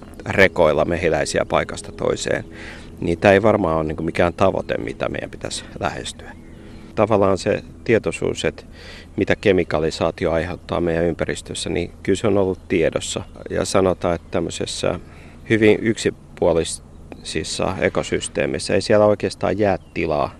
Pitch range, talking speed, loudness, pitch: 80-100 Hz, 125 wpm, -20 LUFS, 85 Hz